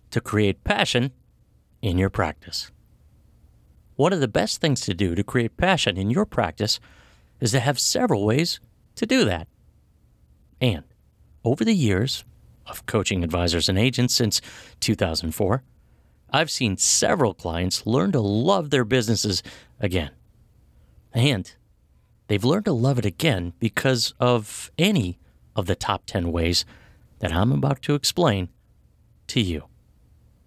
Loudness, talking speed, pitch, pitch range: -23 LUFS, 140 wpm, 105 Hz, 90-125 Hz